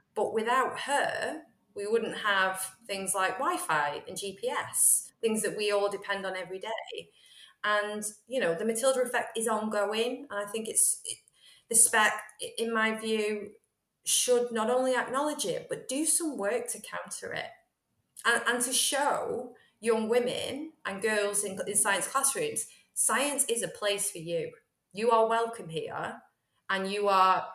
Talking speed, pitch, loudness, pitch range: 160 wpm, 230 Hz, -29 LUFS, 205-270 Hz